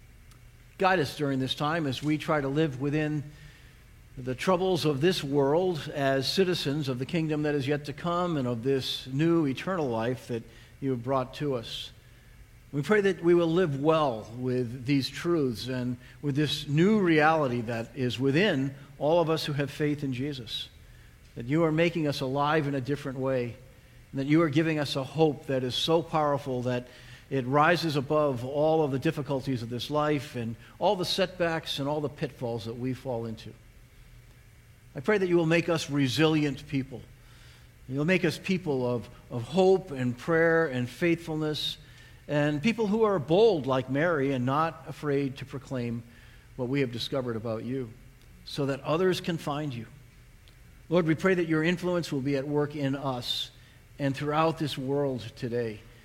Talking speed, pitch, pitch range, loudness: 180 wpm, 140 Hz, 125-155 Hz, -28 LUFS